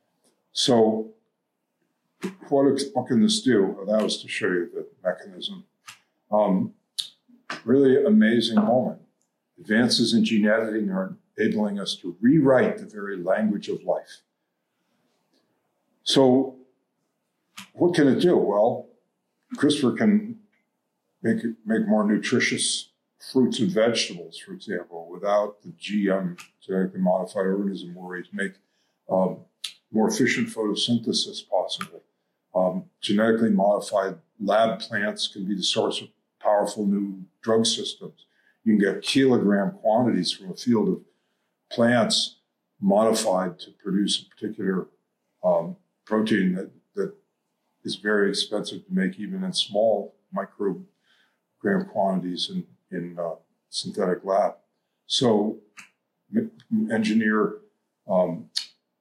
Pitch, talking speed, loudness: 115 Hz, 120 wpm, -24 LUFS